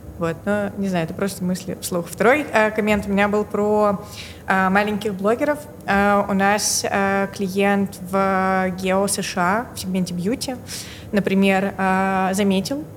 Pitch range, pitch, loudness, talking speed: 190-205 Hz, 200 Hz, -20 LUFS, 155 wpm